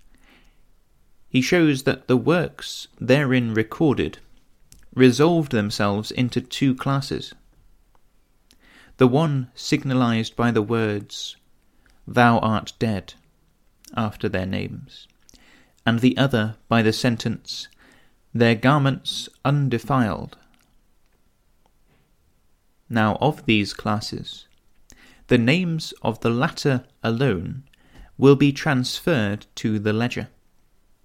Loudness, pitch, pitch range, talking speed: -22 LUFS, 120 Hz, 110-135 Hz, 95 wpm